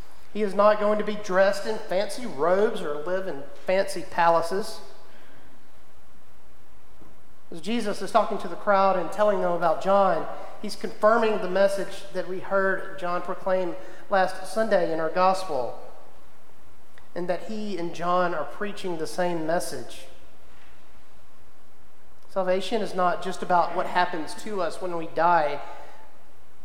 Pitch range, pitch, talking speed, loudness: 170-205 Hz, 185 Hz, 140 wpm, -26 LUFS